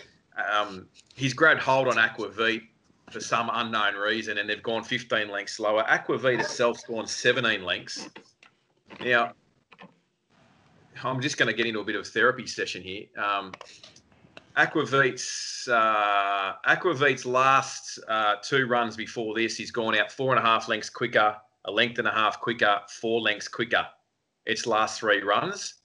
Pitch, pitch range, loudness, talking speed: 115 Hz, 105-125 Hz, -25 LUFS, 155 wpm